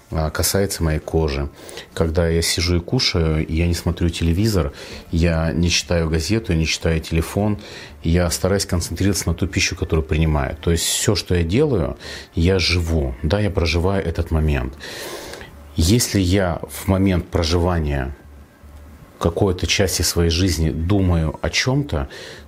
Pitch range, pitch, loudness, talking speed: 80-95 Hz, 85 Hz, -20 LUFS, 140 wpm